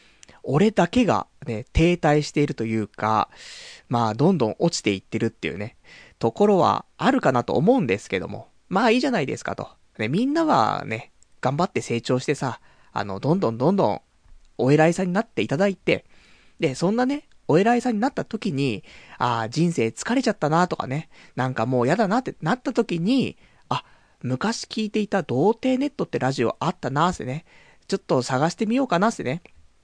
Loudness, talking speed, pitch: -23 LUFS, 370 characters per minute, 170 Hz